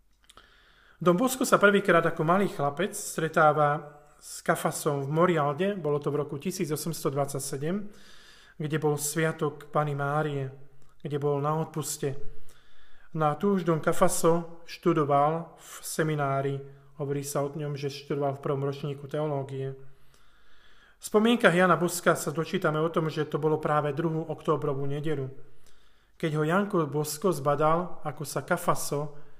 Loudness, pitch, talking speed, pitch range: -28 LUFS, 155 Hz, 140 wpm, 145-170 Hz